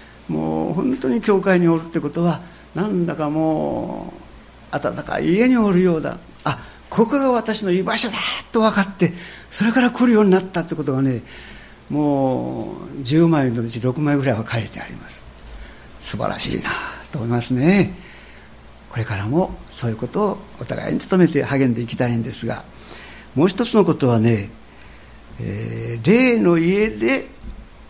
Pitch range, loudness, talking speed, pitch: 120-190 Hz, -19 LUFS, 300 characters per minute, 160 Hz